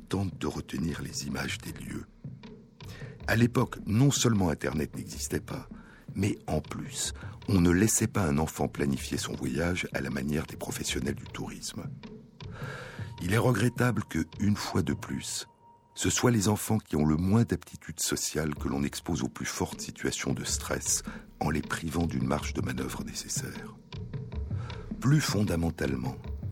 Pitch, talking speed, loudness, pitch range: 95 Hz, 155 wpm, -30 LUFS, 75-115 Hz